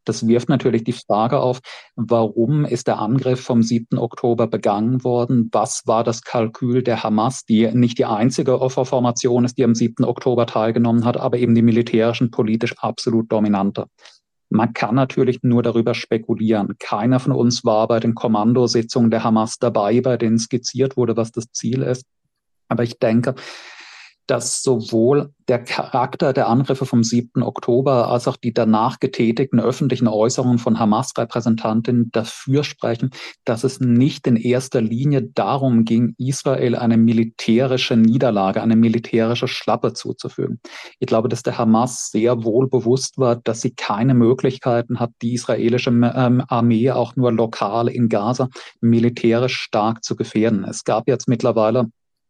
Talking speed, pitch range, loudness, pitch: 155 wpm, 115-125 Hz, -18 LUFS, 120 Hz